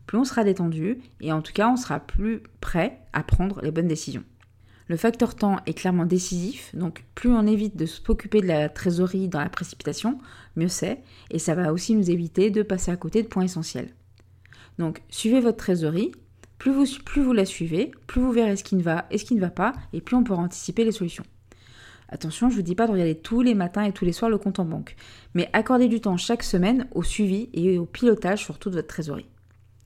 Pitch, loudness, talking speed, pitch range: 185 Hz, -24 LUFS, 225 wpm, 160-220 Hz